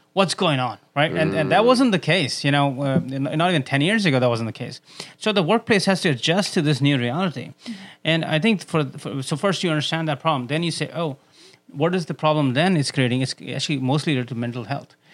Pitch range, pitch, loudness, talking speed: 140-180 Hz, 155 Hz, -21 LUFS, 240 wpm